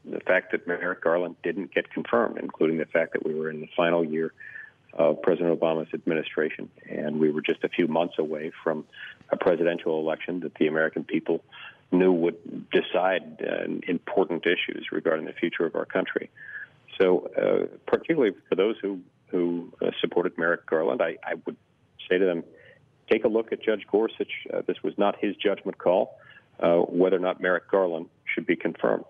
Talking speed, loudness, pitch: 180 wpm, -26 LUFS, 95 Hz